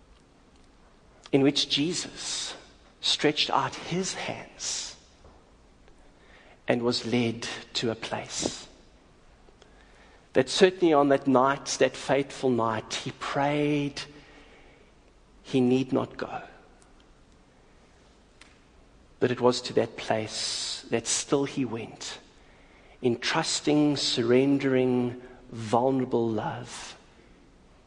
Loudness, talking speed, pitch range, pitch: -27 LUFS, 90 wpm, 115-140 Hz, 125 Hz